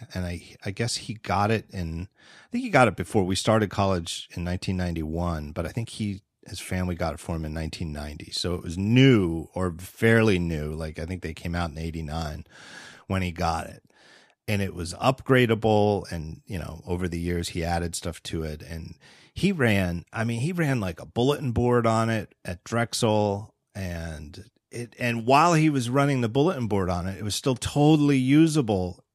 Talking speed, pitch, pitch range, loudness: 200 wpm, 95 Hz, 85-120 Hz, -25 LUFS